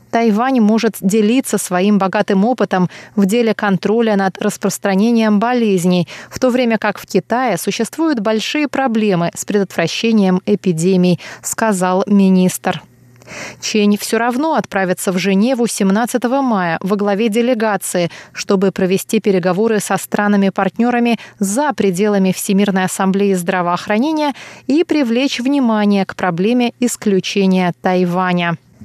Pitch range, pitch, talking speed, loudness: 190-230 Hz, 205 Hz, 110 wpm, -15 LUFS